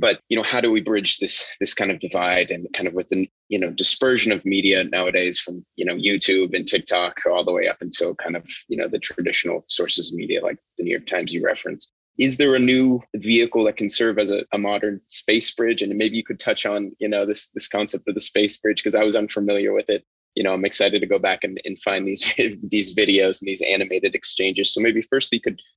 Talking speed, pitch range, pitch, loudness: 250 wpm, 95-115 Hz, 105 Hz, -20 LUFS